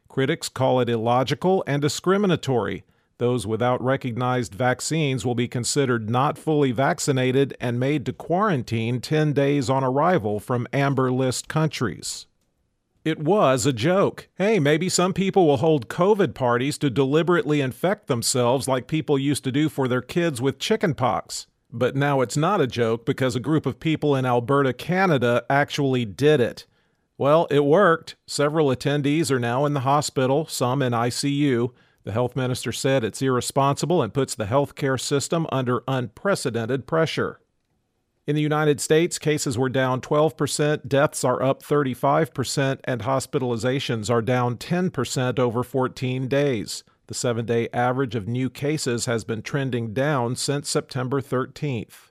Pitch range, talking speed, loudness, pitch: 125-150 Hz, 155 wpm, -23 LUFS, 135 Hz